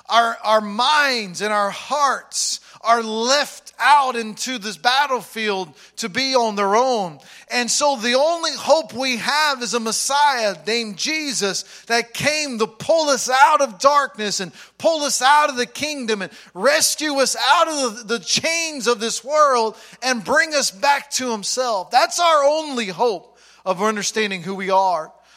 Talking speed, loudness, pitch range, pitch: 165 wpm, -19 LUFS, 220-285 Hz, 245 Hz